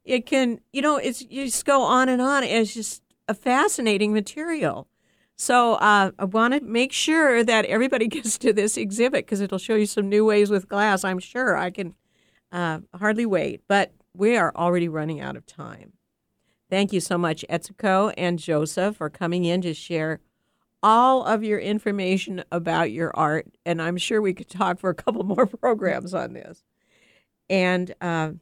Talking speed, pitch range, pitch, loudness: 185 wpm, 175-235 Hz, 205 Hz, -22 LUFS